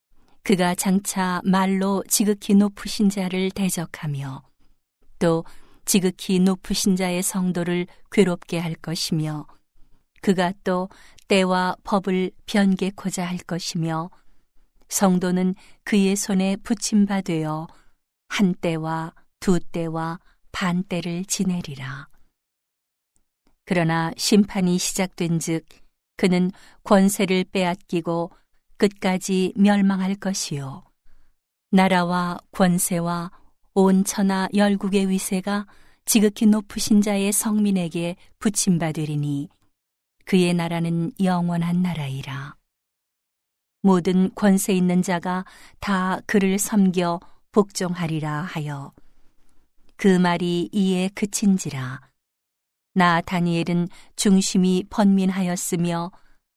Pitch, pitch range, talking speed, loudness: 185 Hz, 170-195 Hz, 205 characters per minute, -22 LUFS